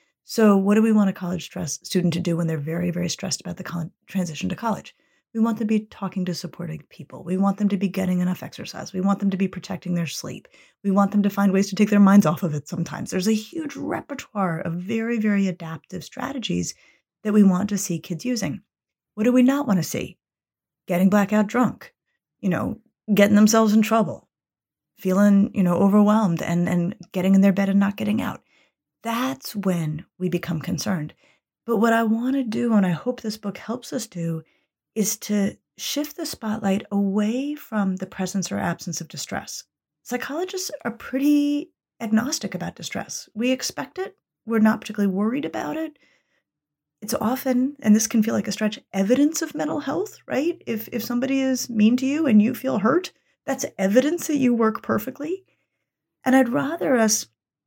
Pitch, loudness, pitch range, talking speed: 210 Hz, -23 LUFS, 185-245 Hz, 195 wpm